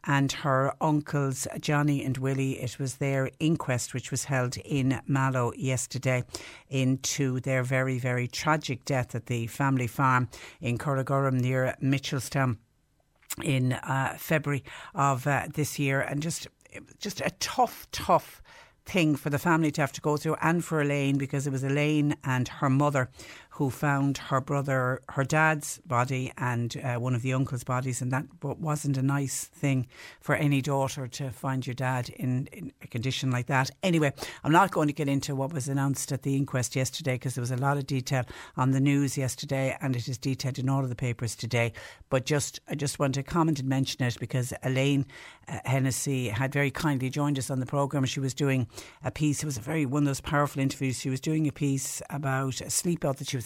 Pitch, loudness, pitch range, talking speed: 135 Hz, -28 LUFS, 130-145 Hz, 200 wpm